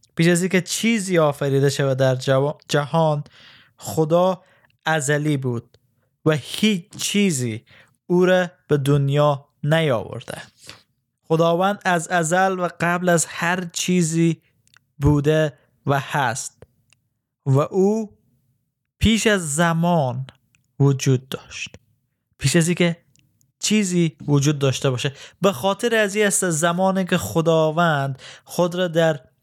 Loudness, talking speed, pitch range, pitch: -20 LUFS, 110 wpm, 135-175 Hz, 155 Hz